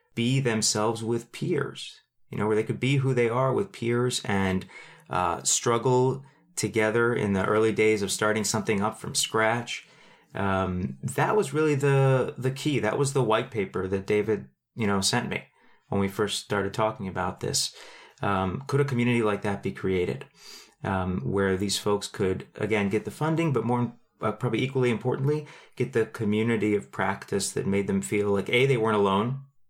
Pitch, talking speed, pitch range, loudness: 110 Hz, 185 wpm, 100-125 Hz, -26 LUFS